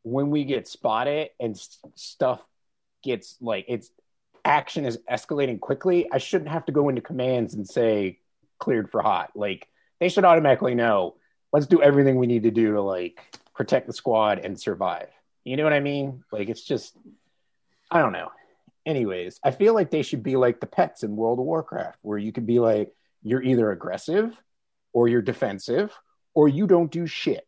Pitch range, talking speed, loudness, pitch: 115-155 Hz, 185 wpm, -24 LUFS, 135 Hz